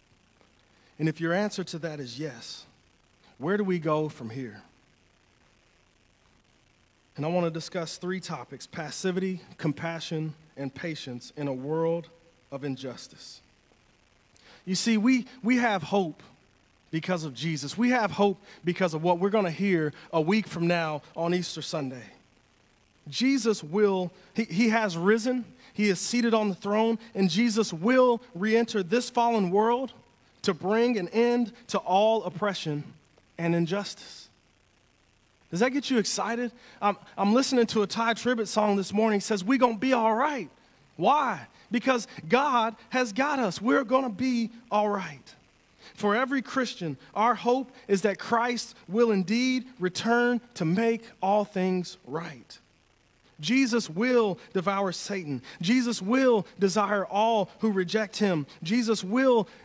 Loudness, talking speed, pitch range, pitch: -27 LUFS, 150 wpm, 165-230 Hz, 200 Hz